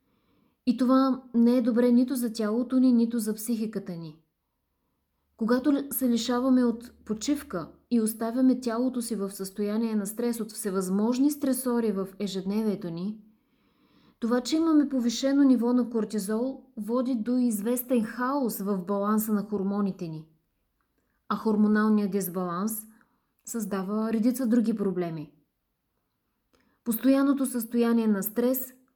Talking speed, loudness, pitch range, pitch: 120 wpm, -27 LUFS, 210-250 Hz, 230 Hz